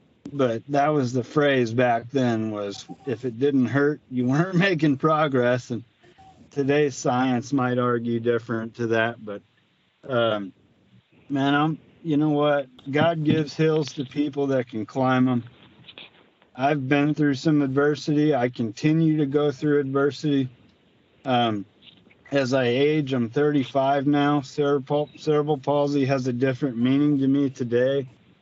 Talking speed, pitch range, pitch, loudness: 145 wpm, 125-145 Hz, 140 Hz, -23 LUFS